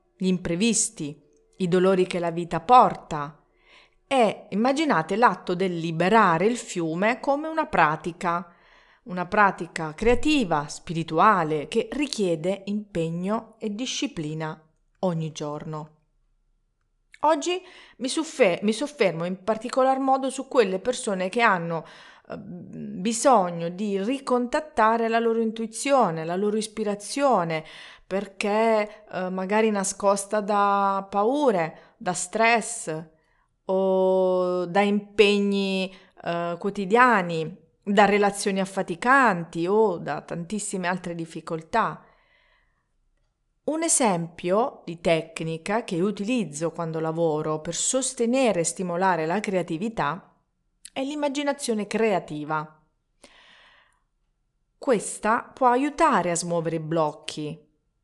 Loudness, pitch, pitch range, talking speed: -24 LUFS, 195 Hz, 170-230 Hz, 95 wpm